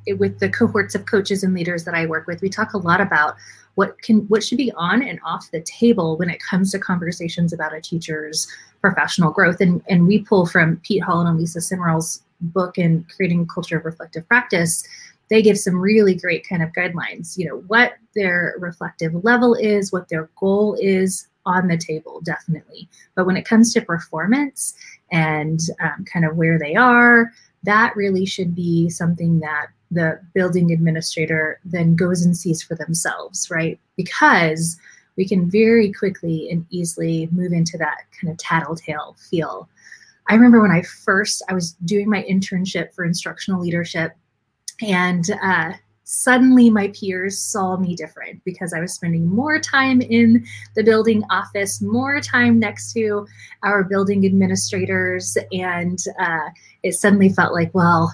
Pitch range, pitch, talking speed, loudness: 165-205 Hz, 180 Hz, 170 wpm, -18 LUFS